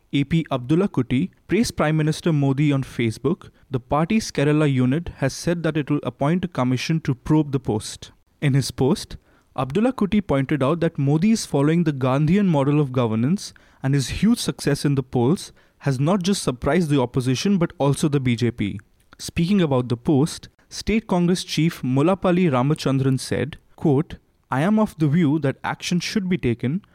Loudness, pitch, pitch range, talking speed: -21 LUFS, 145 Hz, 130-170 Hz, 175 wpm